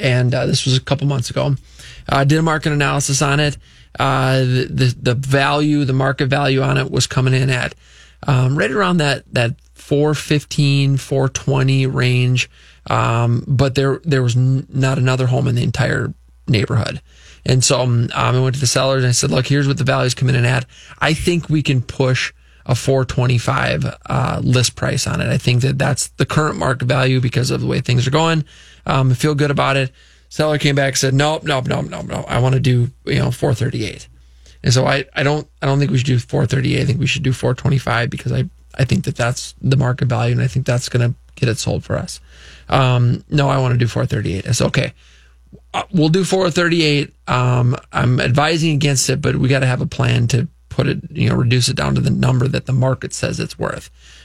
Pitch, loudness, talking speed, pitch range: 130 Hz, -17 LUFS, 230 wpm, 125-140 Hz